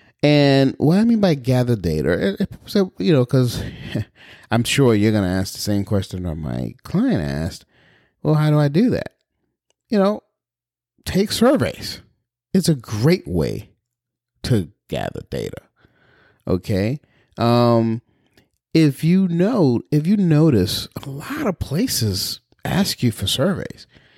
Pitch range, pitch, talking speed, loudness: 105-160 Hz, 125 Hz, 140 wpm, -19 LUFS